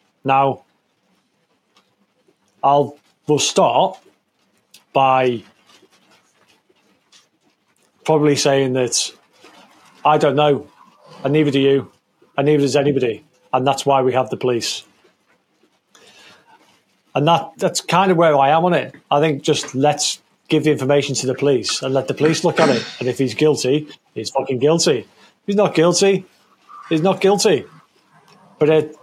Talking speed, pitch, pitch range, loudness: 145 wpm, 145 Hz, 135-160 Hz, -17 LUFS